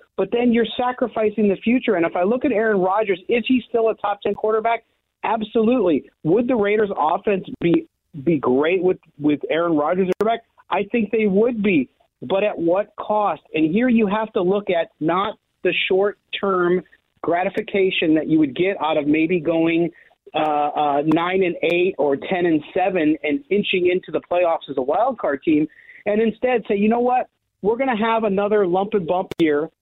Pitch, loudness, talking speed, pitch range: 195 Hz, -20 LUFS, 190 wpm, 165-225 Hz